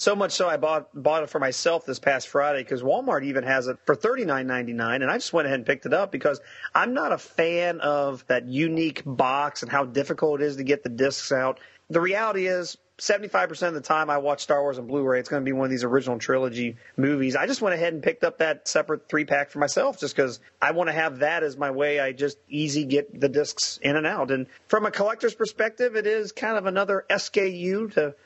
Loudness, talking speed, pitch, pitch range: -25 LUFS, 245 wpm, 145 Hz, 135-180 Hz